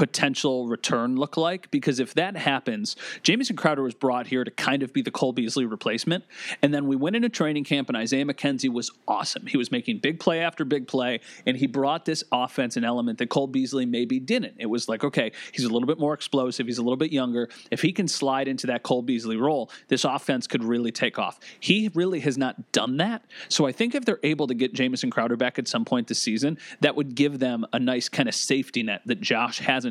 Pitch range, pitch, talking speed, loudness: 125-160 Hz, 140 Hz, 235 wpm, -25 LUFS